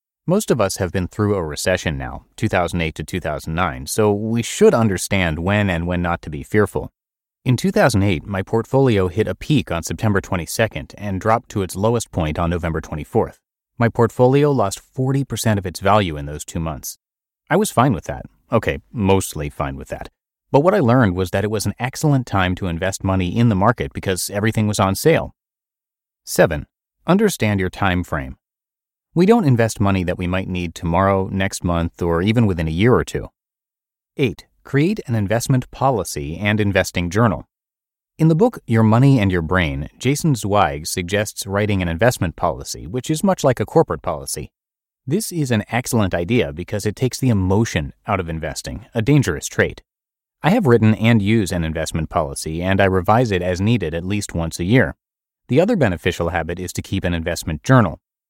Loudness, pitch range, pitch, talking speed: -19 LUFS, 90-115 Hz, 100 Hz, 190 wpm